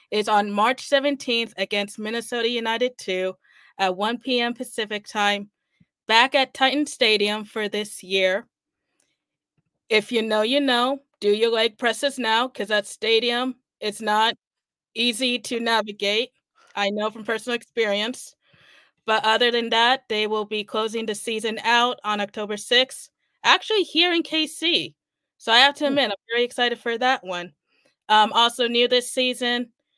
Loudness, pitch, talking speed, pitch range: -22 LUFS, 230 Hz, 155 wpm, 210-250 Hz